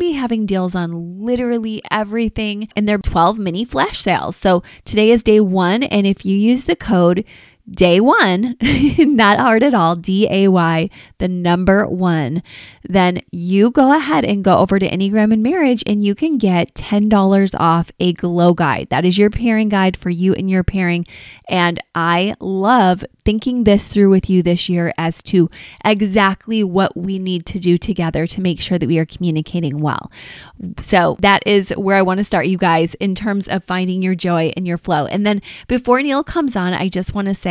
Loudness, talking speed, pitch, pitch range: -15 LUFS, 195 wpm, 195 Hz, 175-215 Hz